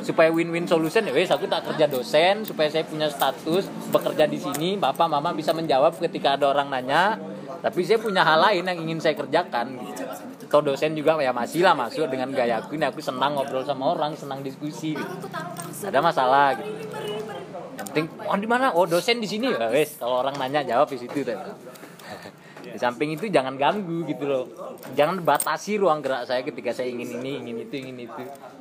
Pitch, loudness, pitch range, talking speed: 155 Hz, -24 LUFS, 135-175 Hz, 195 wpm